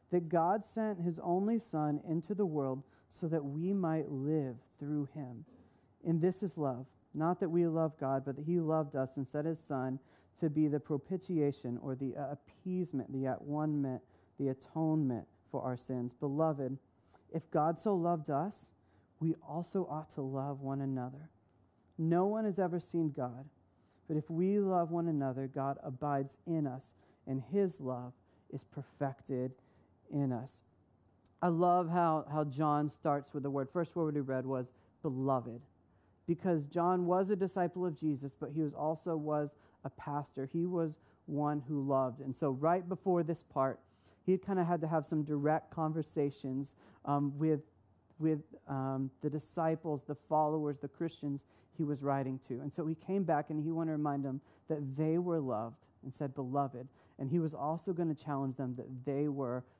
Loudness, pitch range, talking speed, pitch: -36 LUFS, 130-165 Hz, 180 wpm, 145 Hz